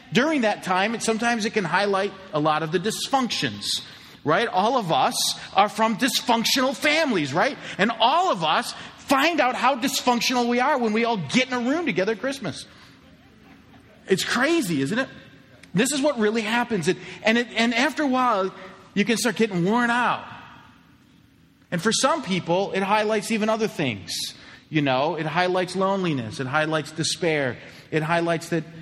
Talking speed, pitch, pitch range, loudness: 180 wpm, 215 Hz, 175-240 Hz, -23 LUFS